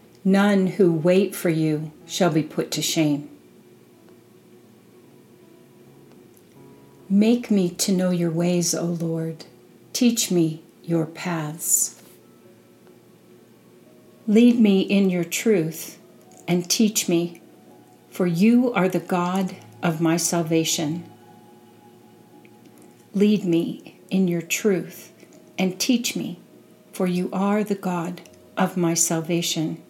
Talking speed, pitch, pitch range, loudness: 110 wpm, 175 Hz, 165-195 Hz, -22 LUFS